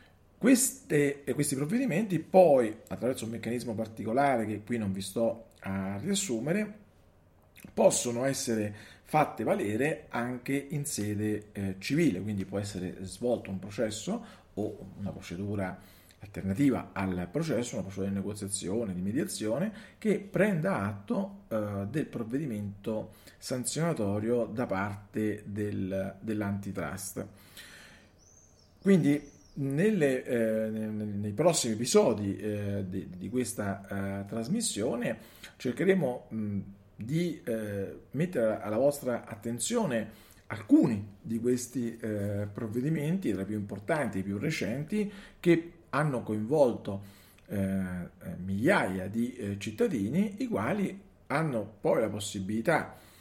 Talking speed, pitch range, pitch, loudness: 115 wpm, 100-140 Hz, 110 Hz, -31 LUFS